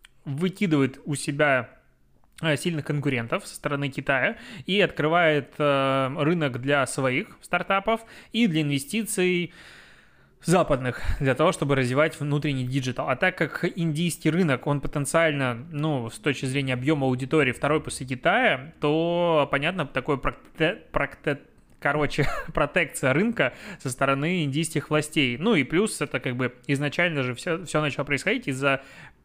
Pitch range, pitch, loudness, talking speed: 135-165 Hz, 150 Hz, -25 LUFS, 130 wpm